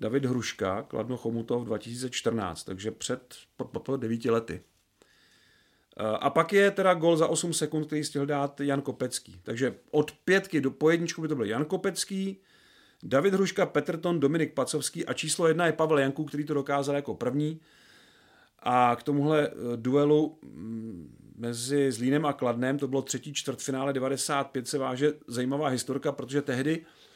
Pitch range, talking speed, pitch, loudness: 125-155 Hz, 155 wpm, 140 Hz, -28 LUFS